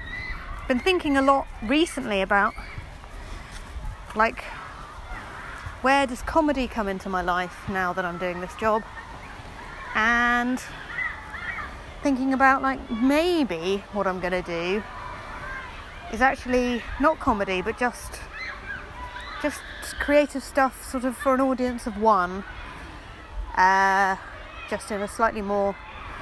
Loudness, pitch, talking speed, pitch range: -24 LUFS, 245 Hz, 120 wpm, 195-270 Hz